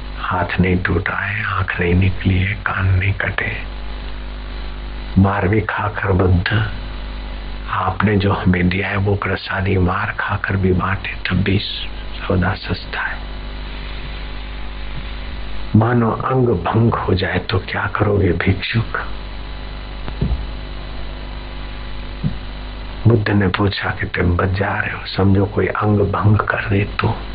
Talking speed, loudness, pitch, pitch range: 120 wpm, -18 LUFS, 95 Hz, 90-105 Hz